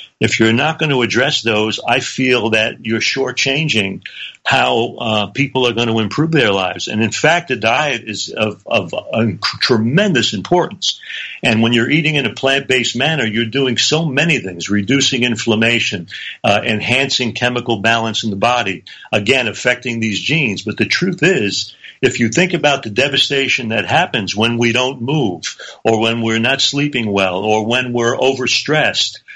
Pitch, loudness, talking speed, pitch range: 120 Hz, -15 LUFS, 170 wpm, 110-135 Hz